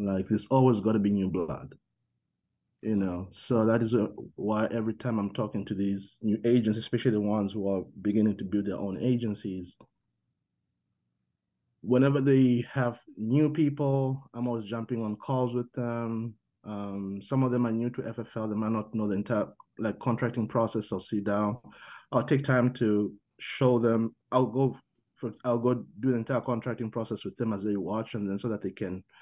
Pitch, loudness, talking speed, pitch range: 115 Hz, -29 LUFS, 195 wpm, 105-120 Hz